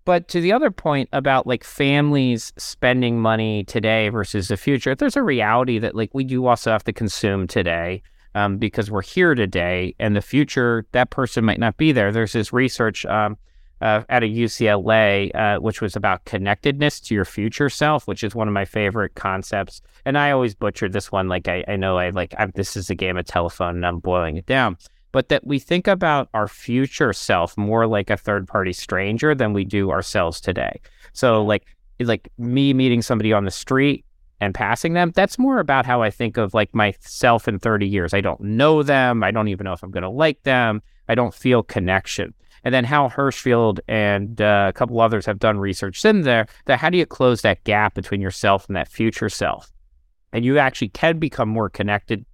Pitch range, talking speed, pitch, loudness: 100-125 Hz, 205 wpm, 110 Hz, -20 LUFS